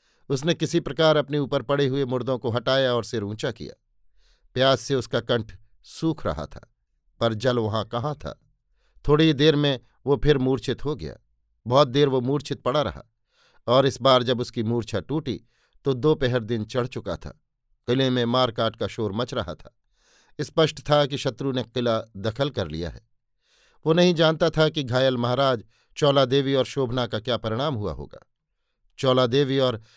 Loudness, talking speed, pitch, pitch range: -24 LUFS, 180 wpm, 130 Hz, 115-140 Hz